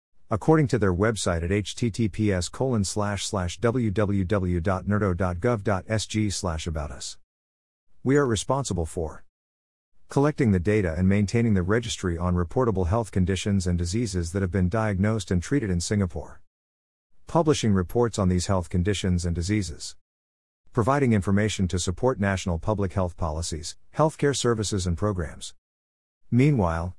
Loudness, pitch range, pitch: -25 LUFS, 85-110 Hz, 95 Hz